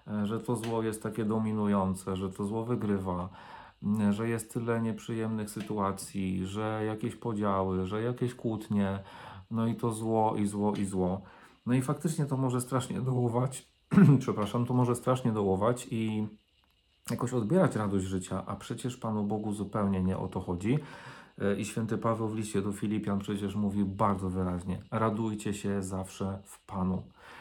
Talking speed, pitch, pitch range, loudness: 155 wpm, 105 Hz, 100-115 Hz, -31 LUFS